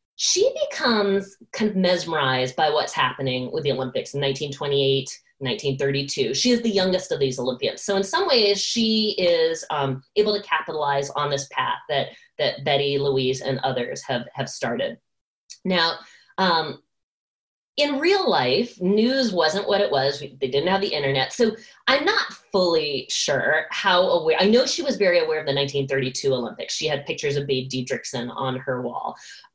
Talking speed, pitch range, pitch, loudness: 170 wpm, 135-225 Hz, 155 Hz, -22 LUFS